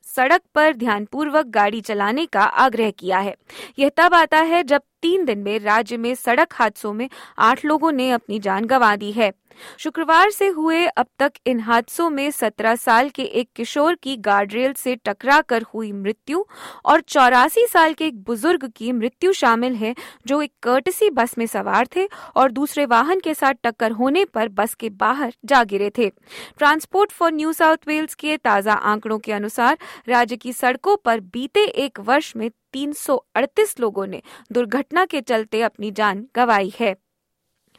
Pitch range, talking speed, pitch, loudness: 225-310 Hz, 175 wpm, 250 Hz, -19 LUFS